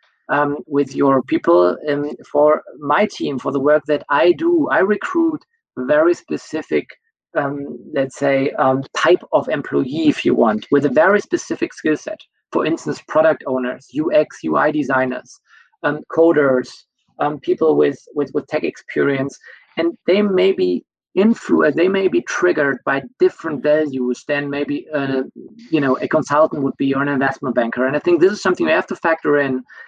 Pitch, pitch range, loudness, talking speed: 150 Hz, 140-205 Hz, -18 LUFS, 170 wpm